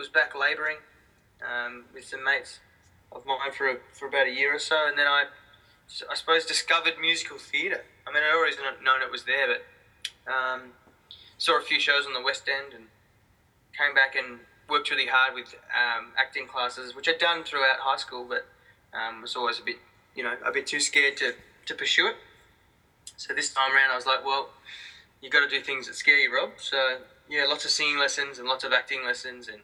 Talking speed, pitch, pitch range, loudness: 215 wpm, 135 Hz, 130-145 Hz, -25 LUFS